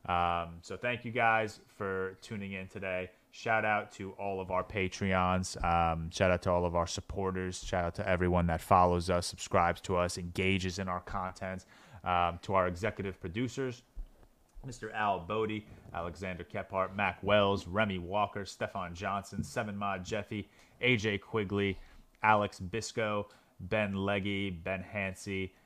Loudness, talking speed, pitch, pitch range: -33 LUFS, 150 wpm, 95 Hz, 90-105 Hz